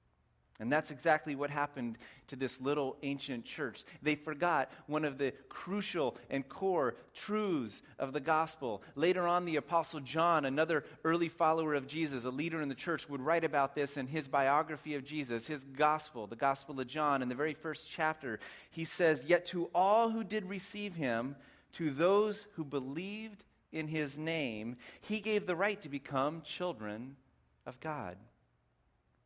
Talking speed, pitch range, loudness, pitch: 170 wpm, 135-170 Hz, -35 LUFS, 155 Hz